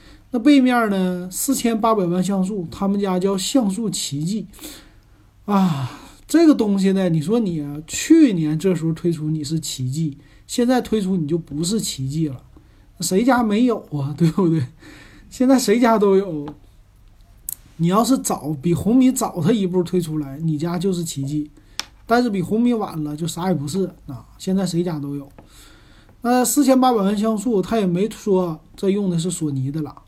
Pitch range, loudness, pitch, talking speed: 150-215 Hz, -20 LUFS, 180 Hz, 245 characters per minute